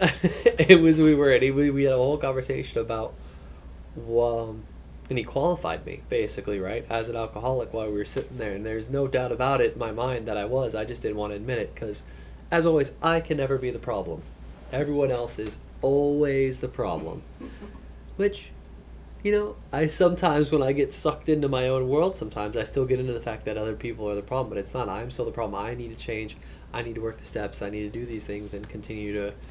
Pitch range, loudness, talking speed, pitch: 105-140 Hz, -26 LUFS, 230 wpm, 120 Hz